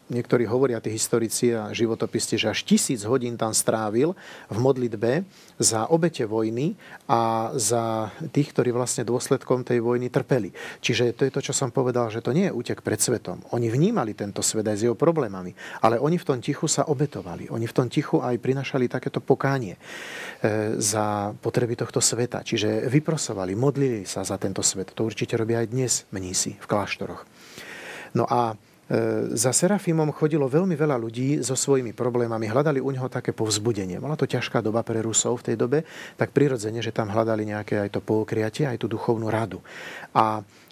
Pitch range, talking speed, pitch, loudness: 110-135 Hz, 180 wpm, 120 Hz, -24 LUFS